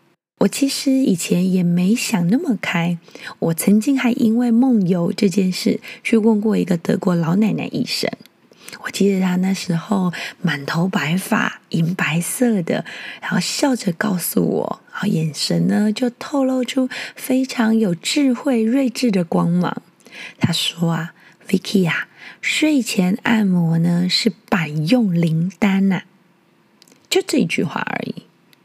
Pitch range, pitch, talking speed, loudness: 180-240 Hz, 205 Hz, 215 characters per minute, -19 LUFS